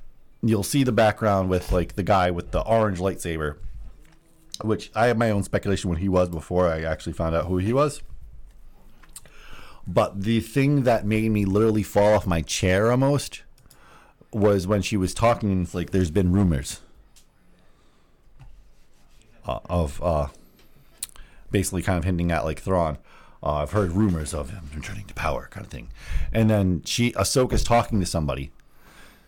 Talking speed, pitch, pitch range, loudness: 160 wpm, 95 Hz, 85-110 Hz, -23 LUFS